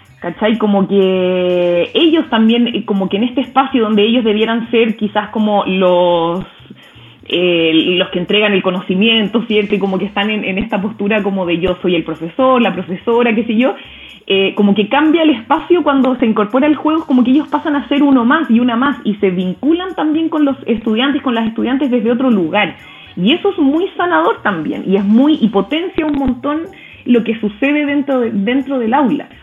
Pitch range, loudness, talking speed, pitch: 195-275 Hz, -13 LUFS, 200 wpm, 225 Hz